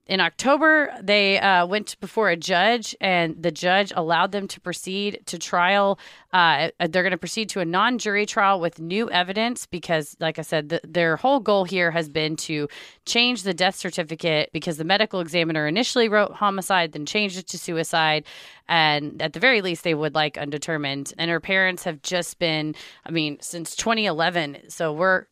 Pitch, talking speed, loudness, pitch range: 175 Hz, 185 wpm, -22 LUFS, 165-200 Hz